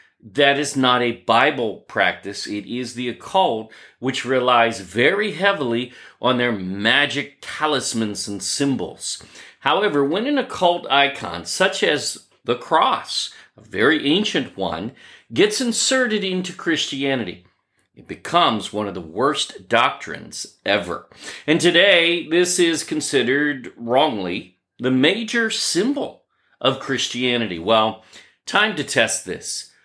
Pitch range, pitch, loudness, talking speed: 120-175 Hz, 135 Hz, -20 LUFS, 125 wpm